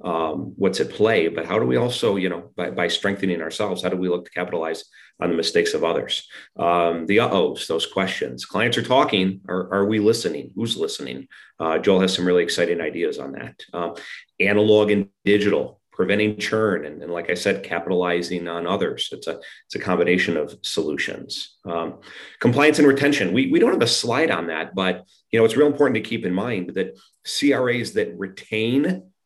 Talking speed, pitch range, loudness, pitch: 200 wpm, 90-115 Hz, -21 LUFS, 100 Hz